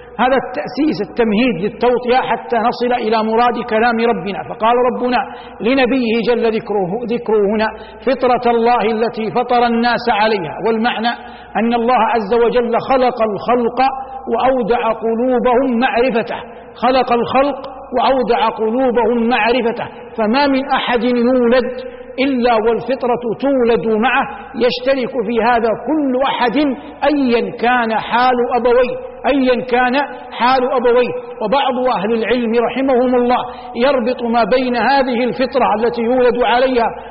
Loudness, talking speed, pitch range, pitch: -15 LUFS, 115 wpm, 230-255 Hz, 245 Hz